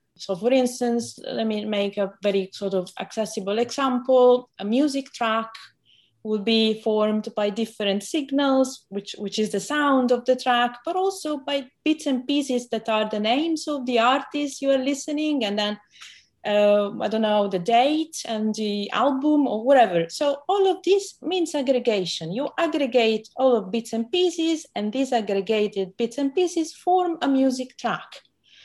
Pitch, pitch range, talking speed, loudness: 245 Hz, 210-280 Hz, 170 wpm, -23 LUFS